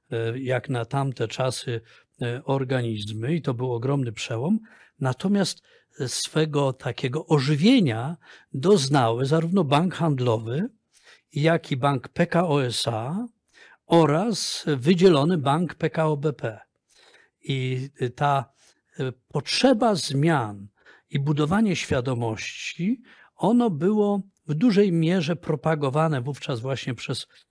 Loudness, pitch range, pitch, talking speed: -24 LUFS, 130-175 Hz, 145 Hz, 95 wpm